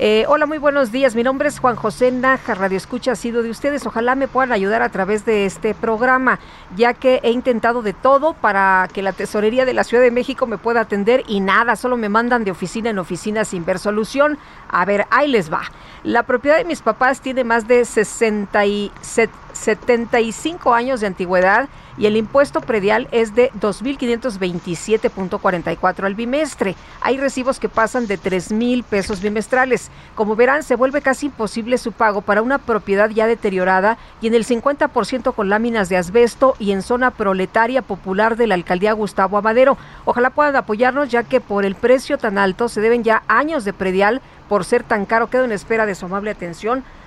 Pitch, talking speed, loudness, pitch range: 230 Hz, 190 wpm, -17 LUFS, 205-255 Hz